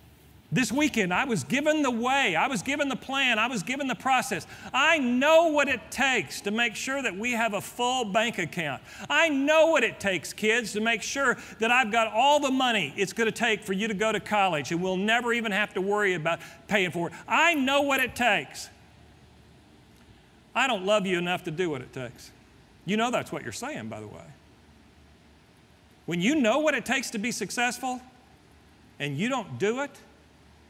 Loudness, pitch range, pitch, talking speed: -25 LUFS, 180-255 Hz, 220 Hz, 205 wpm